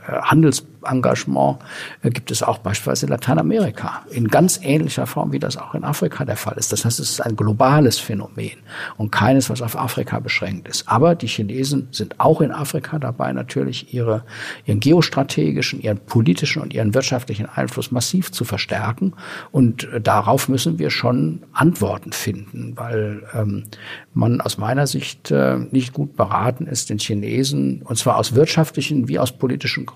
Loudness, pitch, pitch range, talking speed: -19 LUFS, 120 Hz, 105-140 Hz, 165 wpm